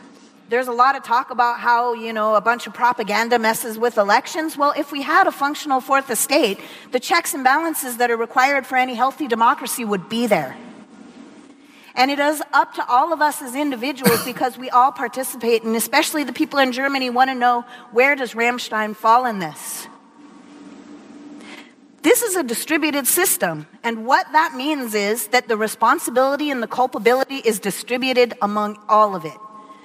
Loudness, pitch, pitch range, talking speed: -19 LUFS, 250 Hz, 230-285 Hz, 180 wpm